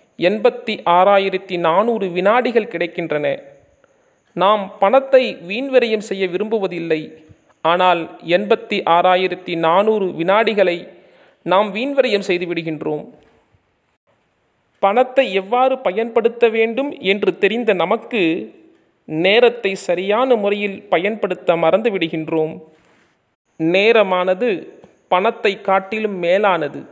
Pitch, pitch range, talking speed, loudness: 195 Hz, 180-230 Hz, 80 wpm, -17 LUFS